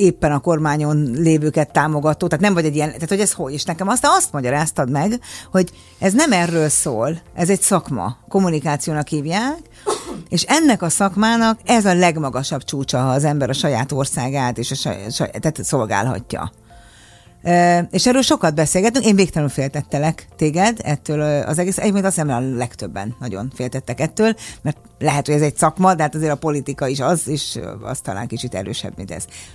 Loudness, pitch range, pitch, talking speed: -18 LUFS, 130-175 Hz, 150 Hz, 180 wpm